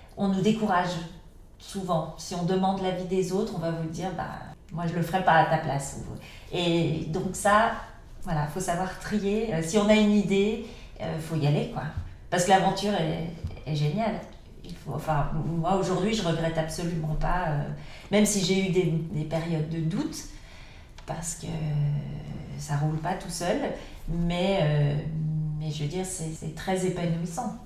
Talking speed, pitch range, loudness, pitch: 180 wpm, 155-190 Hz, -27 LUFS, 170 Hz